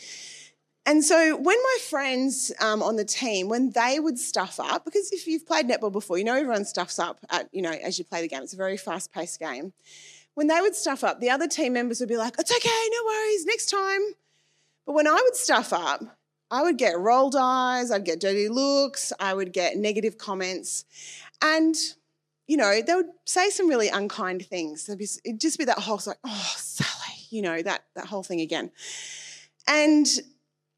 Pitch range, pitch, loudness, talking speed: 195-325 Hz, 255 Hz, -25 LUFS, 200 wpm